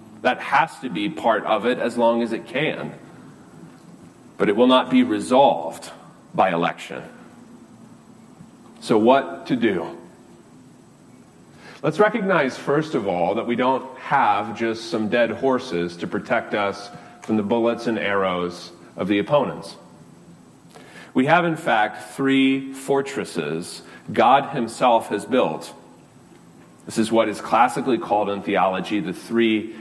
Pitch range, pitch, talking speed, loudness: 90-125 Hz, 110 Hz, 135 wpm, -21 LUFS